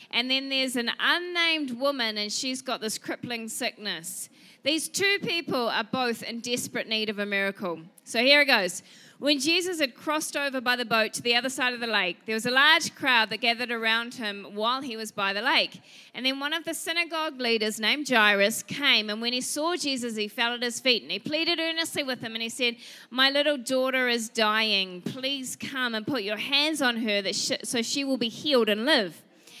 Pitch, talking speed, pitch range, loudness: 245 Hz, 220 wpm, 220-280 Hz, -25 LUFS